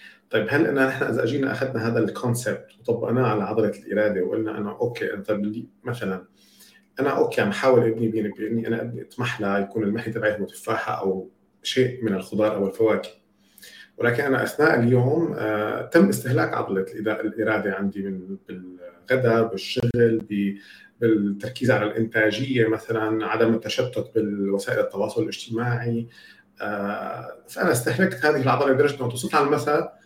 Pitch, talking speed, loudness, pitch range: 110 Hz, 135 wpm, -23 LUFS, 105-120 Hz